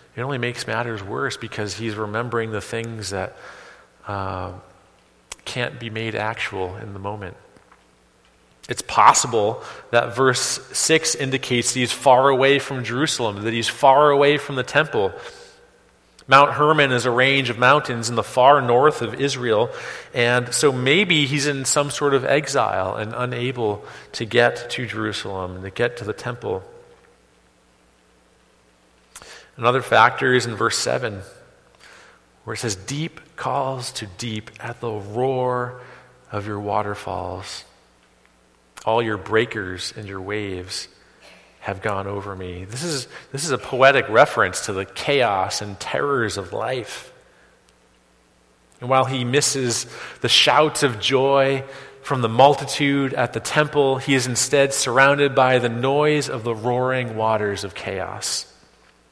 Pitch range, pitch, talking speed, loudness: 100-135 Hz, 120 Hz, 145 wpm, -20 LUFS